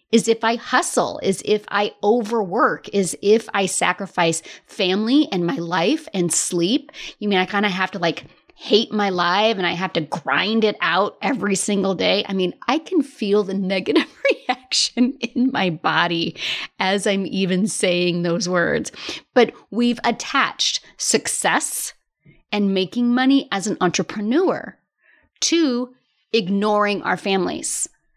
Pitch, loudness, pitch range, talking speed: 205 Hz, -20 LUFS, 185-240 Hz, 150 wpm